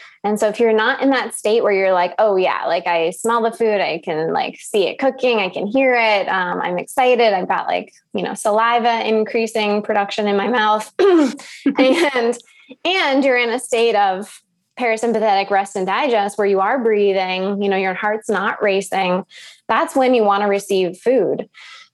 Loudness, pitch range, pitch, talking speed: -17 LUFS, 195-245 Hz, 215 Hz, 190 wpm